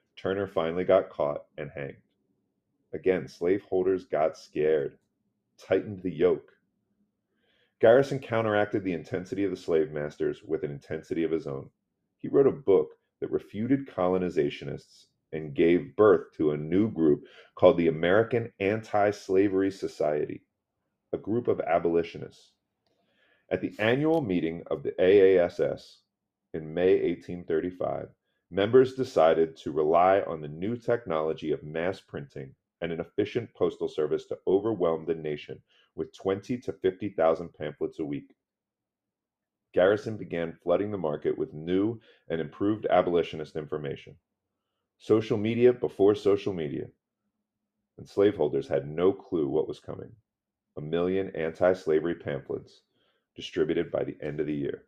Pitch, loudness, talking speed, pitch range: 95 Hz, -27 LUFS, 135 wpm, 85-140 Hz